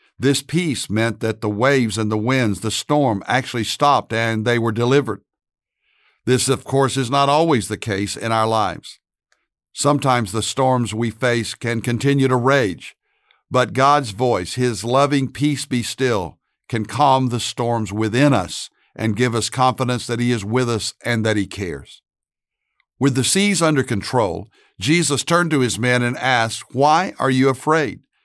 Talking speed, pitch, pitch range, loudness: 170 wpm, 125 Hz, 110-135 Hz, -19 LUFS